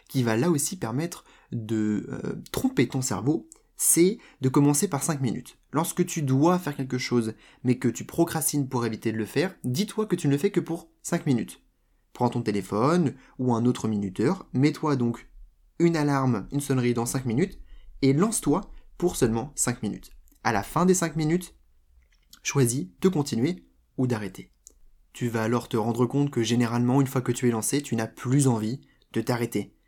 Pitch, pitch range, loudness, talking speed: 130 Hz, 115-150 Hz, -26 LUFS, 190 wpm